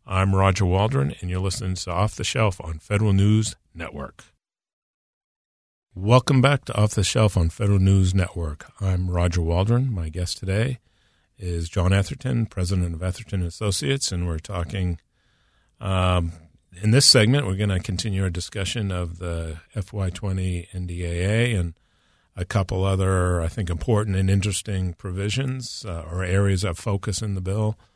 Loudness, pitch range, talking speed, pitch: -23 LUFS, 90-105 Hz, 155 wpm, 95 Hz